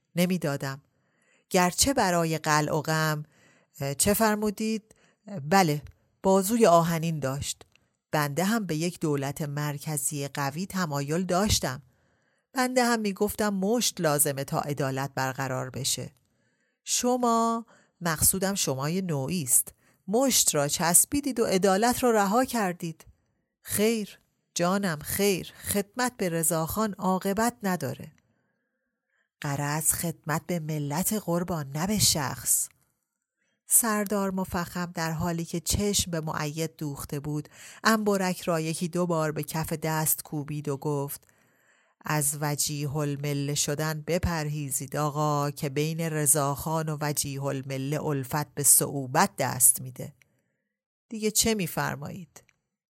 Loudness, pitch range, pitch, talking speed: -26 LUFS, 145-195 Hz, 160 Hz, 110 wpm